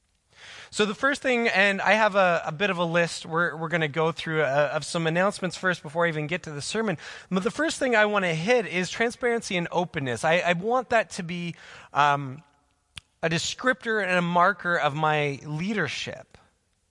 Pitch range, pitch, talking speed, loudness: 155-205 Hz, 175 Hz, 205 wpm, -25 LUFS